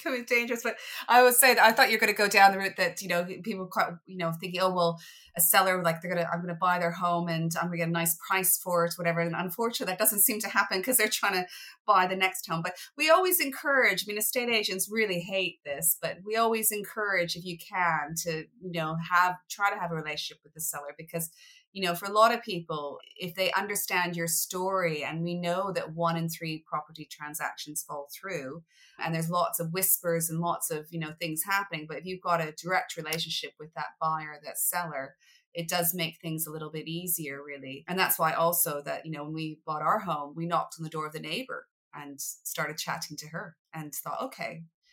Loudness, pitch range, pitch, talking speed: -28 LUFS, 160-190 Hz, 175 Hz, 240 wpm